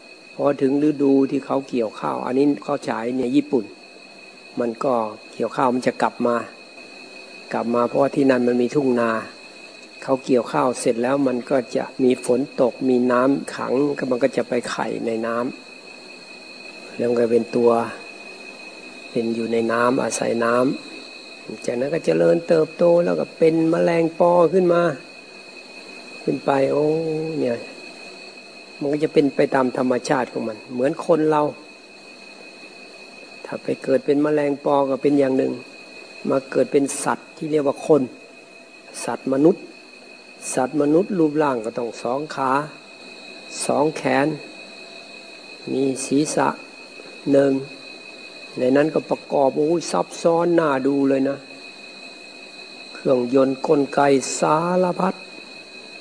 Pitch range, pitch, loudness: 125-150 Hz, 135 Hz, -20 LUFS